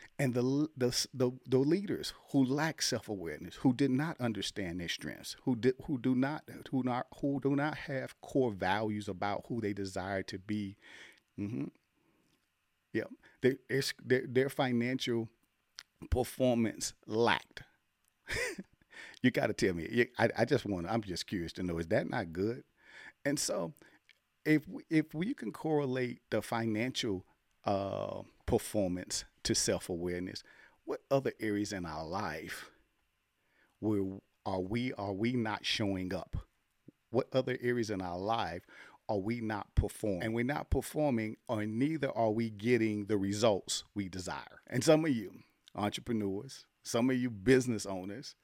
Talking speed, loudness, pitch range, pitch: 150 wpm, -34 LUFS, 100-130 Hz, 115 Hz